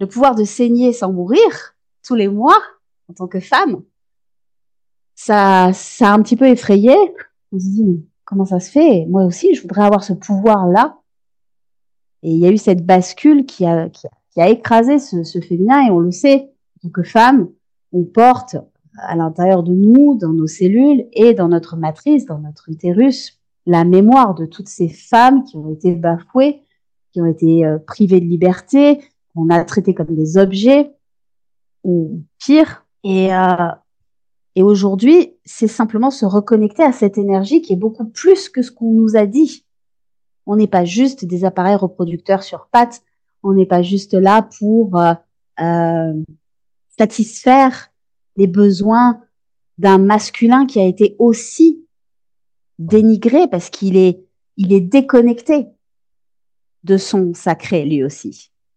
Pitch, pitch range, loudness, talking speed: 200 Hz, 180-245 Hz, -13 LUFS, 165 wpm